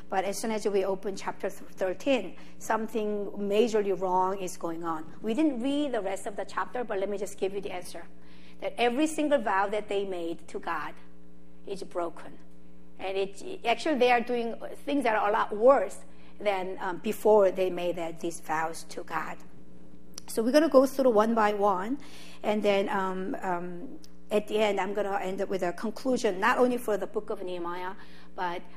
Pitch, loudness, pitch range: 200 Hz, -29 LUFS, 180-220 Hz